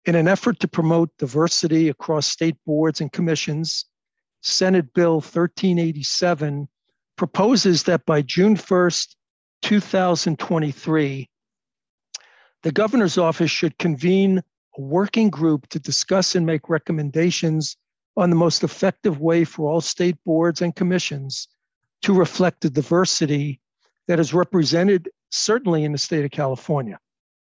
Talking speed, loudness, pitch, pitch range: 125 wpm, -20 LUFS, 170 Hz, 155-180 Hz